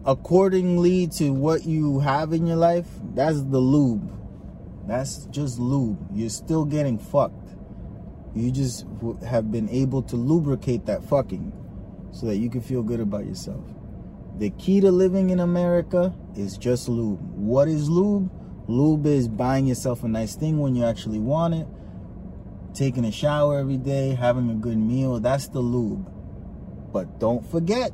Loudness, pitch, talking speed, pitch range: -23 LUFS, 130 Hz, 160 wpm, 115-155 Hz